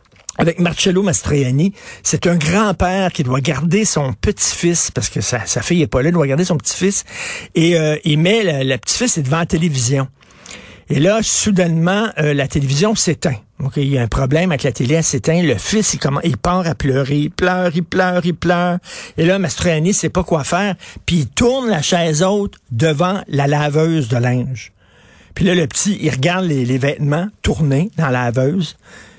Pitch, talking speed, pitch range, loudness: 160 Hz, 200 wpm, 140-180 Hz, -16 LUFS